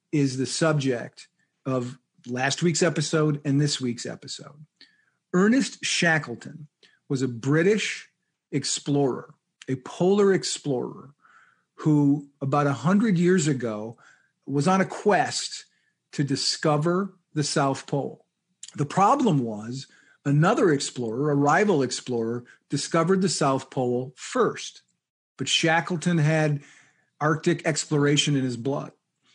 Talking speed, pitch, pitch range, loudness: 110 wpm, 145 Hz, 135-170 Hz, -24 LUFS